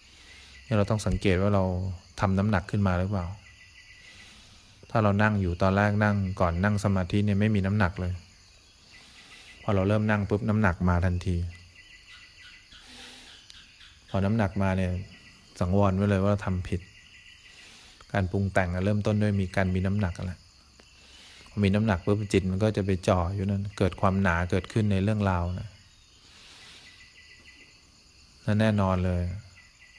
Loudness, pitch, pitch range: -27 LUFS, 95 Hz, 90-105 Hz